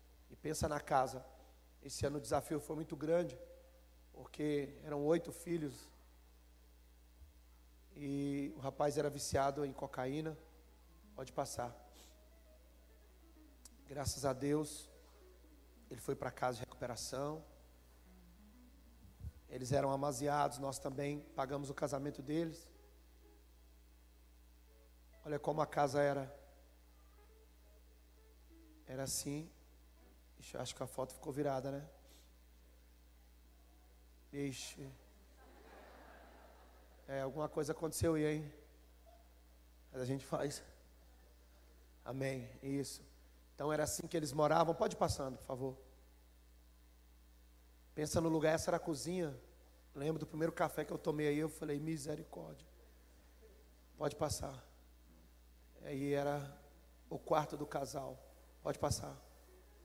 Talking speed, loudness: 110 wpm, -40 LUFS